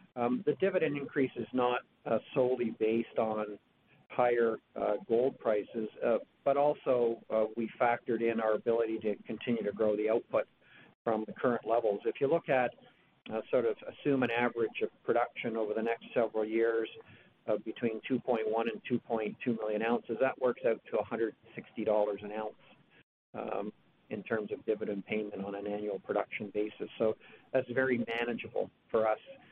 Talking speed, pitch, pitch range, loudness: 165 wpm, 115 Hz, 110-125 Hz, -33 LUFS